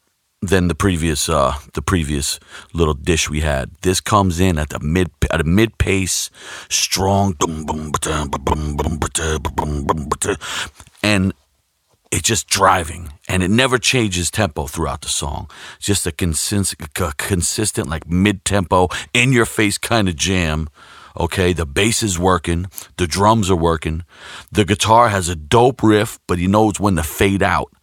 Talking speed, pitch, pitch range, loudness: 150 wpm, 90 Hz, 80-100 Hz, -17 LUFS